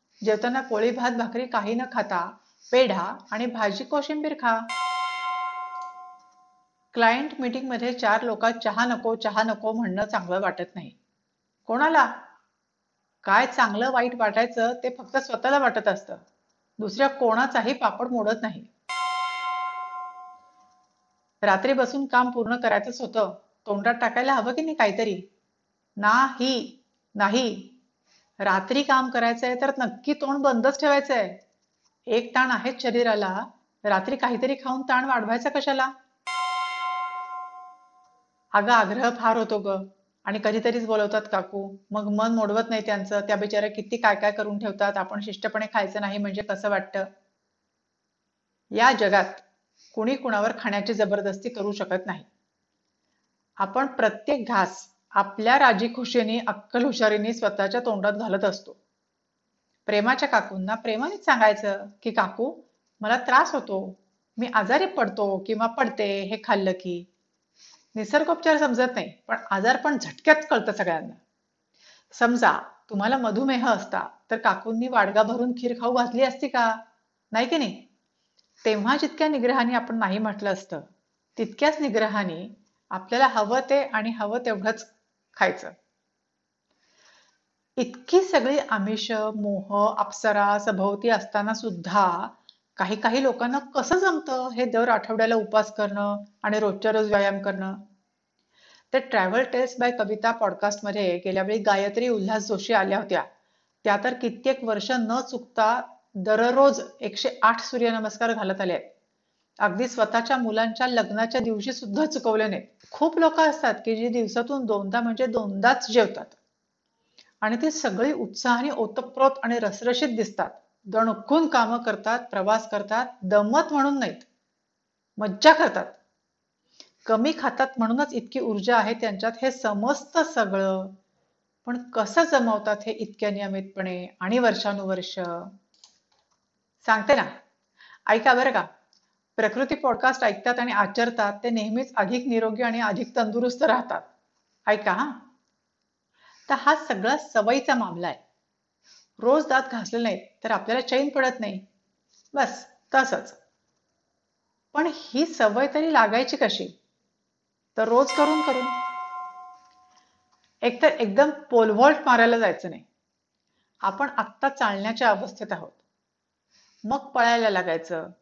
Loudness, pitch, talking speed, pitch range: -24 LUFS, 230 Hz, 120 wpm, 210-260 Hz